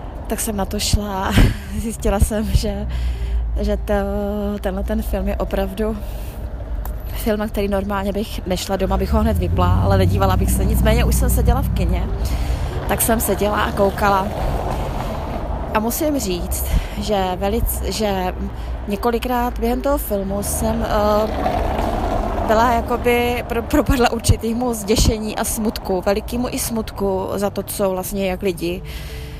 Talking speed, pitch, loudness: 140 wpm, 200 Hz, -20 LUFS